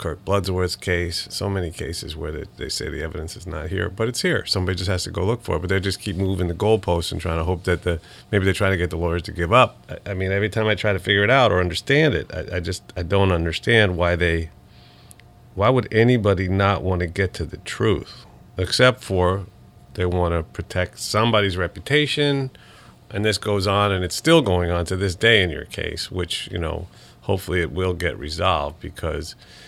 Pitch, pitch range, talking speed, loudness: 95 Hz, 90-105 Hz, 230 wpm, -21 LUFS